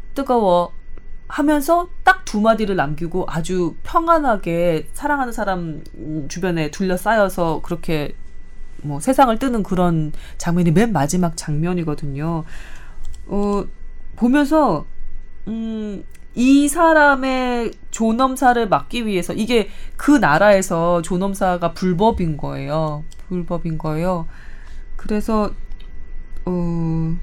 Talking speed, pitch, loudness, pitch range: 225 characters per minute, 180 Hz, -19 LUFS, 160-225 Hz